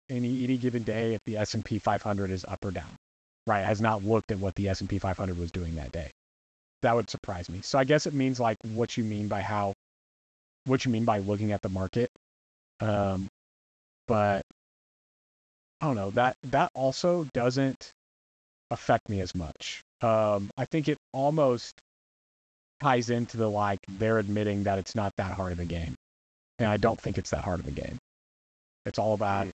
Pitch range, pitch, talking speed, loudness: 95-120 Hz, 105 Hz, 200 wpm, -29 LUFS